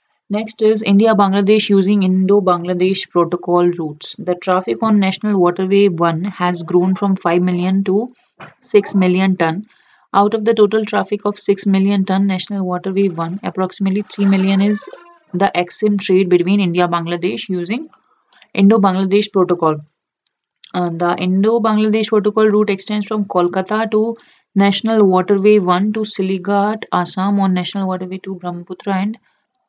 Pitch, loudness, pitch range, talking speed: 195 Hz, -16 LUFS, 180-210 Hz, 145 wpm